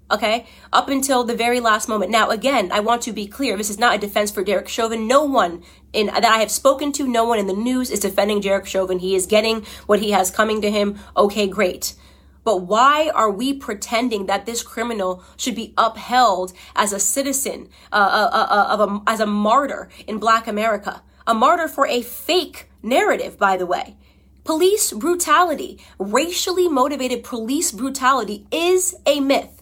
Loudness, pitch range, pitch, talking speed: -19 LUFS, 205-265 Hz, 225 Hz, 190 wpm